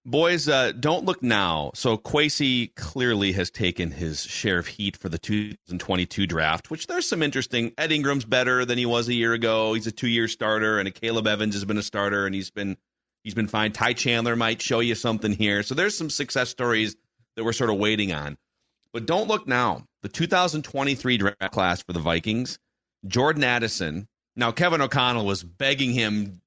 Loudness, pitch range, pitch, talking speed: -24 LUFS, 100-125 Hz, 115 Hz, 195 wpm